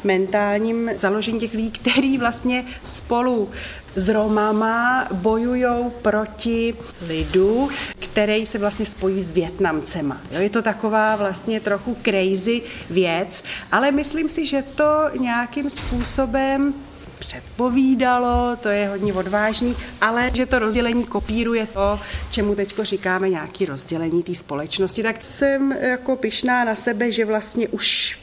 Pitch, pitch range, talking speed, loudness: 220 Hz, 200-245 Hz, 130 wpm, -21 LUFS